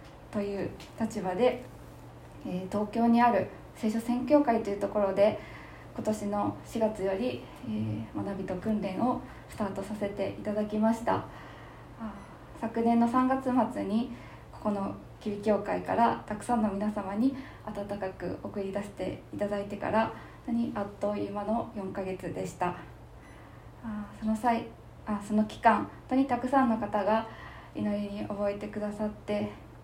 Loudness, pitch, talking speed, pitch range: -31 LUFS, 210 Hz, 265 characters per minute, 200-230 Hz